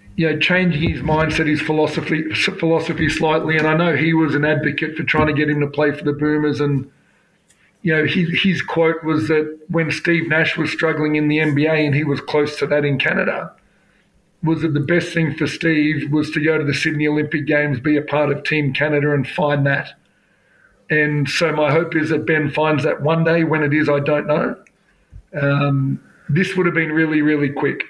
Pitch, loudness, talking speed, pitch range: 155 Hz, -18 LUFS, 215 wpm, 150-160 Hz